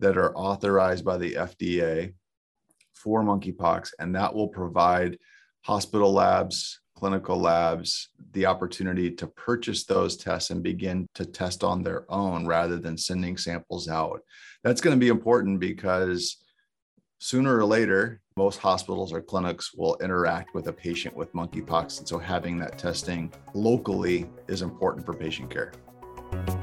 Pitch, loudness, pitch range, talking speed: 95 Hz, -27 LUFS, 85-100 Hz, 145 wpm